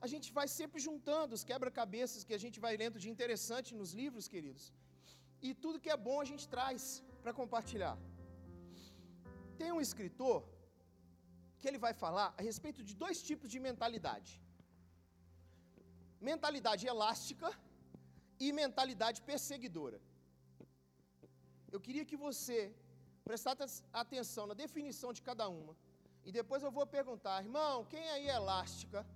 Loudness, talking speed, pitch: -42 LUFS, 140 wpm, 225 Hz